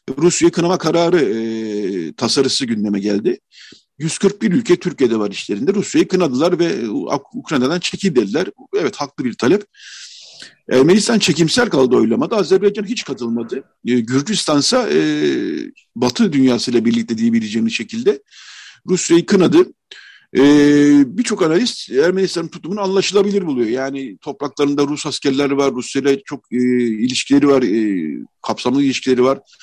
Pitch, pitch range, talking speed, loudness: 170 Hz, 130-215 Hz, 120 wpm, -16 LUFS